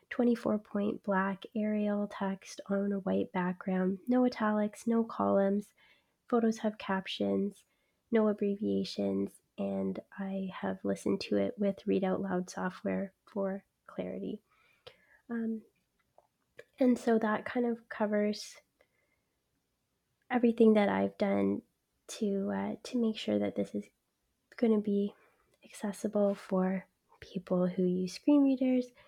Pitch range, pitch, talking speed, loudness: 185-220 Hz, 200 Hz, 125 wpm, -32 LUFS